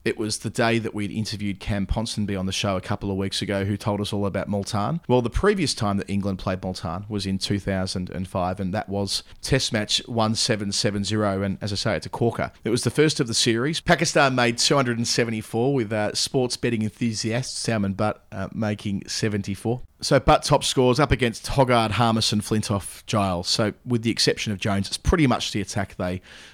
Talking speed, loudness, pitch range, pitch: 200 wpm, -23 LUFS, 100-120 Hz, 110 Hz